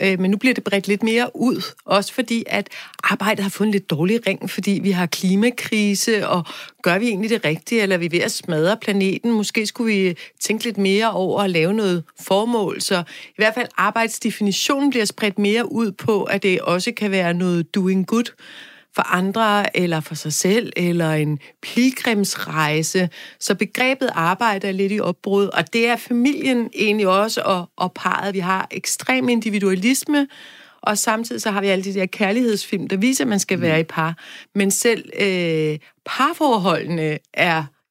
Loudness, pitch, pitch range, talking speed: -19 LUFS, 200 Hz, 185-230 Hz, 180 wpm